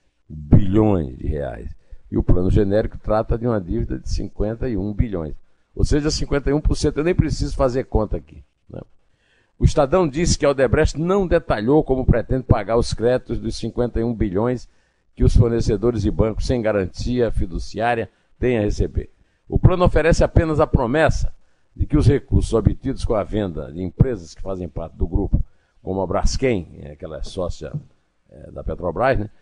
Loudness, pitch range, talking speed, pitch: -21 LUFS, 95-130 Hz, 165 wpm, 110 Hz